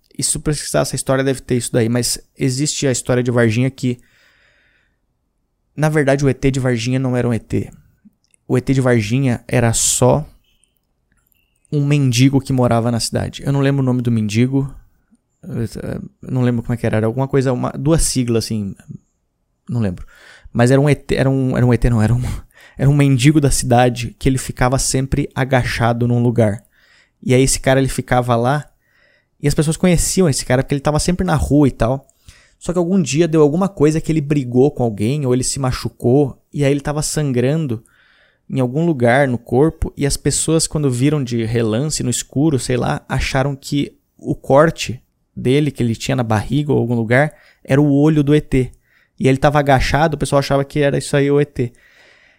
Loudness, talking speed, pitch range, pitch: -16 LUFS, 195 wpm, 120-145 Hz, 130 Hz